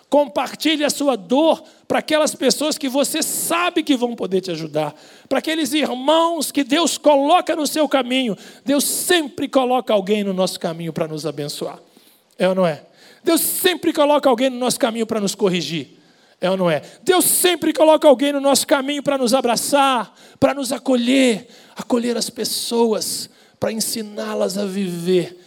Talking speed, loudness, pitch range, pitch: 170 wpm, -18 LUFS, 205-290 Hz, 260 Hz